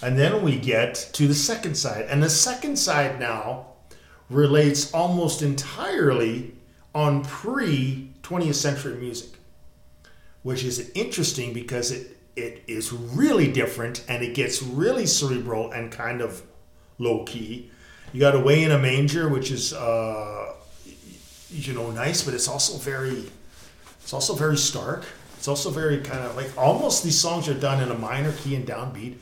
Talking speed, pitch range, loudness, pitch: 160 wpm, 120-145 Hz, -24 LUFS, 130 Hz